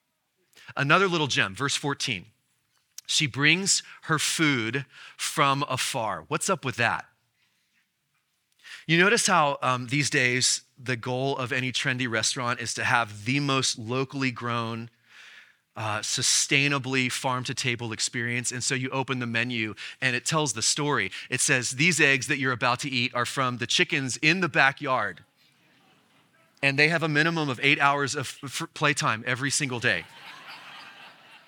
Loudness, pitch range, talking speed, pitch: -25 LUFS, 125-145 Hz, 155 wpm, 135 Hz